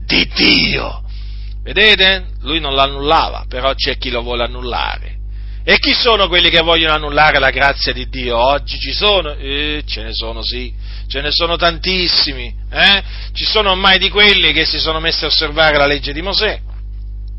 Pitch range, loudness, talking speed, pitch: 115-170 Hz, -12 LUFS, 175 wpm, 140 Hz